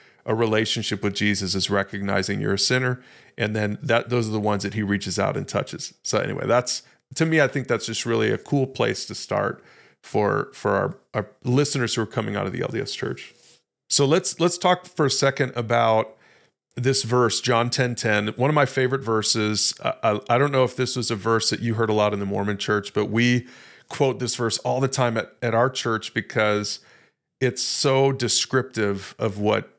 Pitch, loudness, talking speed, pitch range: 115 Hz, -23 LUFS, 215 wpm, 105-130 Hz